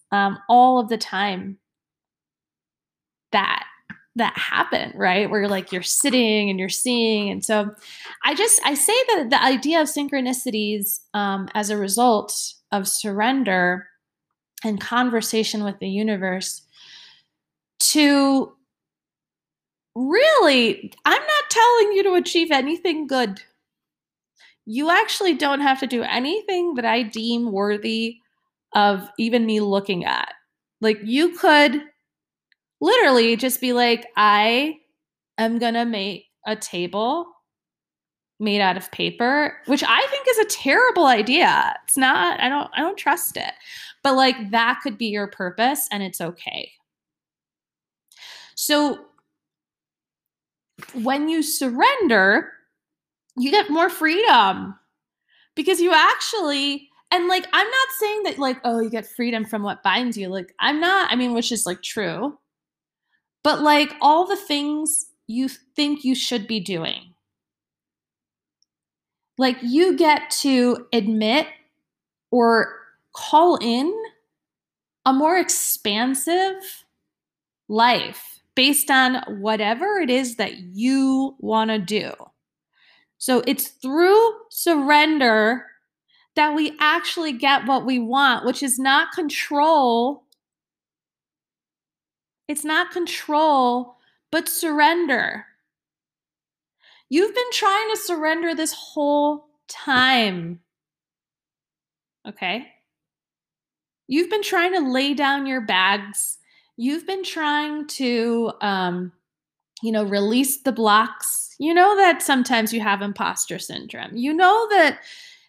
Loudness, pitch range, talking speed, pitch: -20 LUFS, 220-320 Hz, 120 wpm, 265 Hz